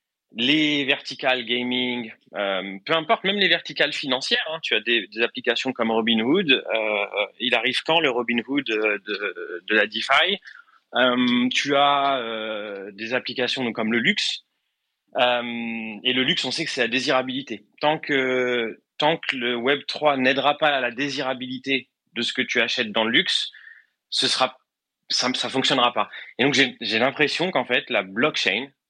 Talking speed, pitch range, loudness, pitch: 170 wpm, 115-140 Hz, -22 LUFS, 125 Hz